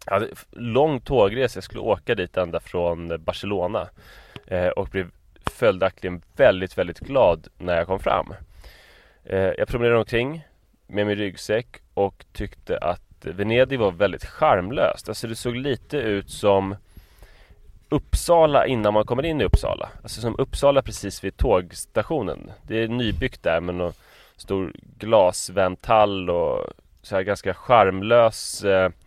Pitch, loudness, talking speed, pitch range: 100 Hz, -23 LUFS, 140 wpm, 90-120 Hz